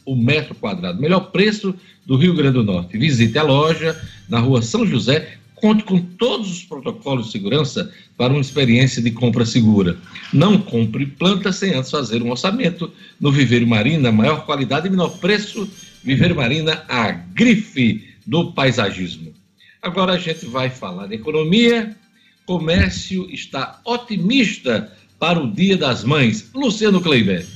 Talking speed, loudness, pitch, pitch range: 150 wpm, -17 LUFS, 160 Hz, 125-195 Hz